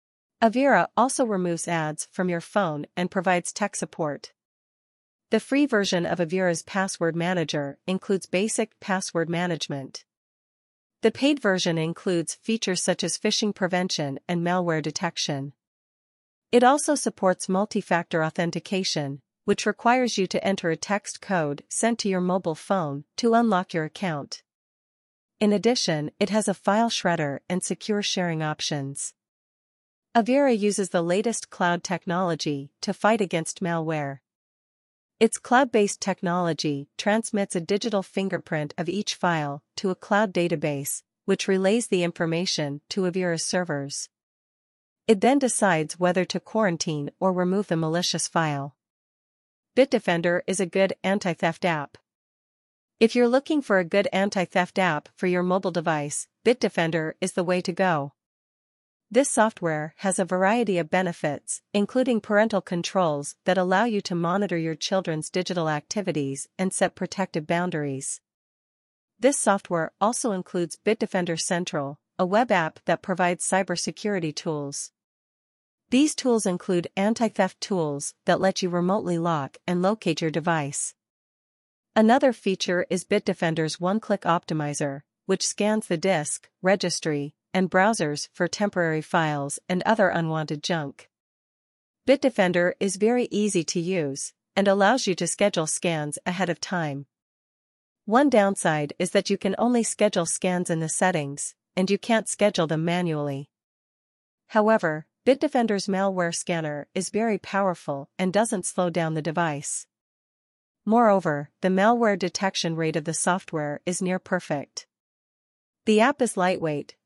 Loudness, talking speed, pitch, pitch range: -25 LUFS, 135 wpm, 180 Hz, 165-205 Hz